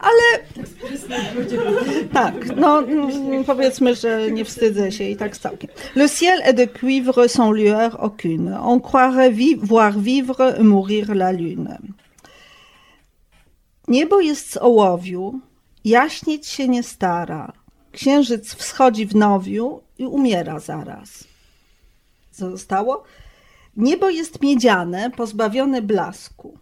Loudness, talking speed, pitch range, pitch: -18 LUFS, 110 wpm, 205-265 Hz, 240 Hz